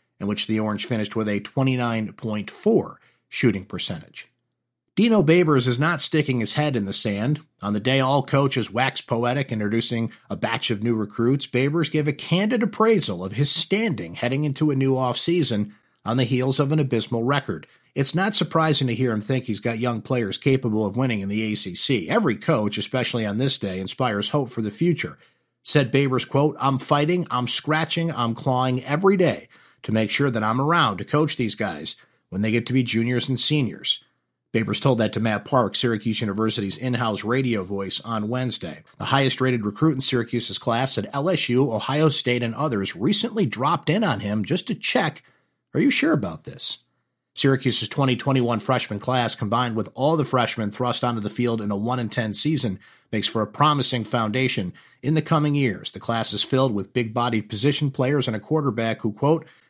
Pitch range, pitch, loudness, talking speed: 110-145 Hz, 125 Hz, -22 LUFS, 190 wpm